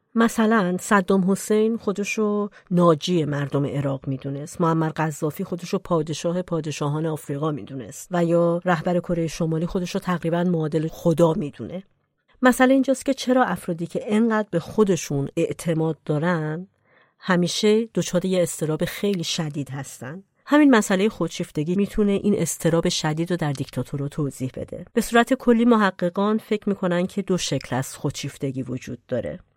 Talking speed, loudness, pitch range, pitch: 145 wpm, -23 LUFS, 155-200 Hz, 175 Hz